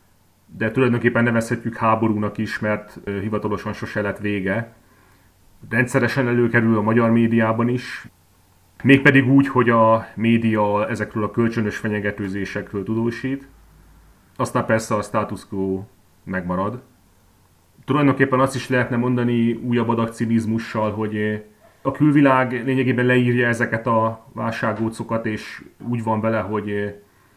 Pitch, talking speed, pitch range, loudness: 110 Hz, 115 wpm, 105-120 Hz, -20 LUFS